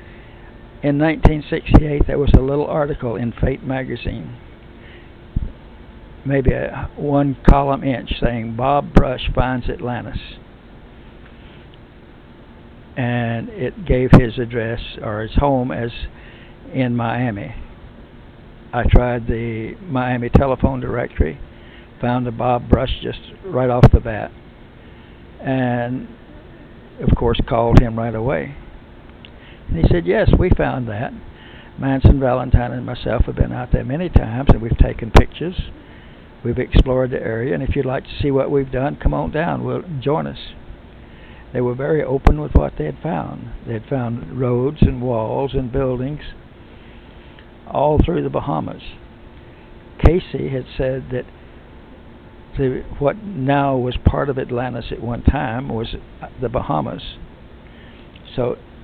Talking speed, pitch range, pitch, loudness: 135 wpm, 115-135 Hz, 125 Hz, -19 LUFS